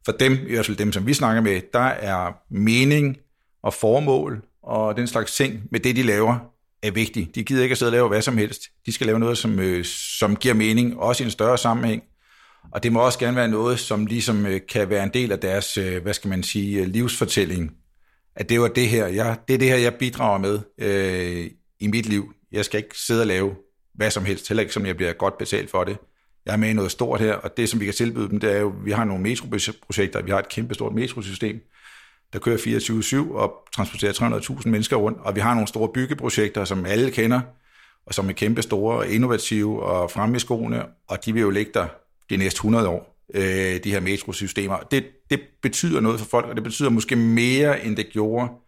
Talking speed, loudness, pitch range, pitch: 230 wpm, -22 LUFS, 100-120 Hz, 110 Hz